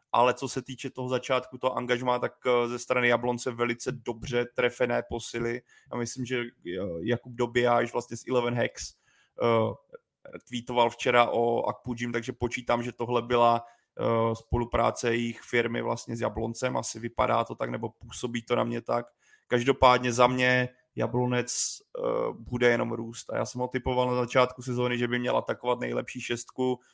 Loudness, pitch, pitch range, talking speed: -28 LUFS, 120 Hz, 120-125 Hz, 160 wpm